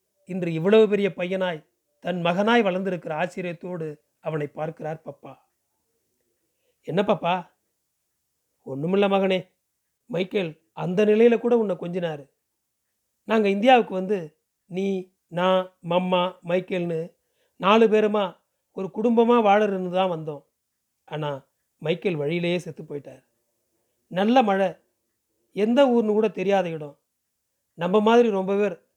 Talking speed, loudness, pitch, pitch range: 105 wpm, -23 LUFS, 185 Hz, 160-205 Hz